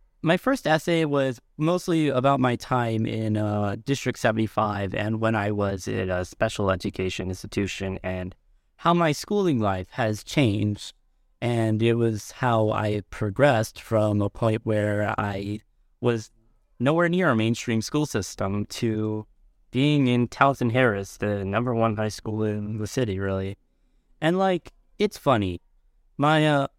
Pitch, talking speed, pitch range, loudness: 110 Hz, 150 wpm, 105-130 Hz, -25 LUFS